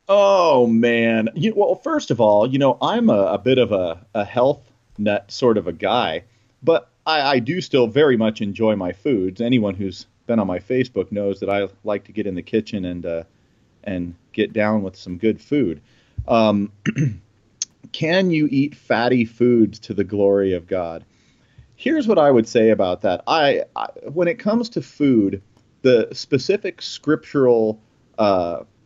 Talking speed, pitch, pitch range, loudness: 175 wpm, 110 Hz, 100-130 Hz, -19 LUFS